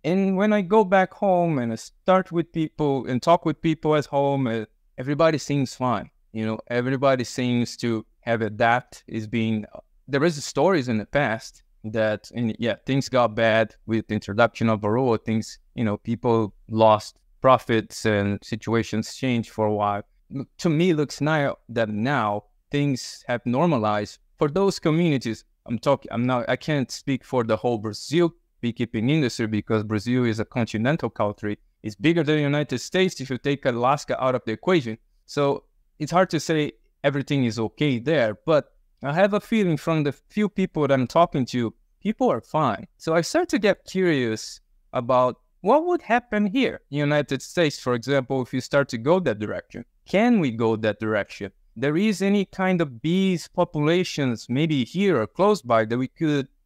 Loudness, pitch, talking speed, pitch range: -23 LUFS, 130 Hz, 185 wpm, 115-160 Hz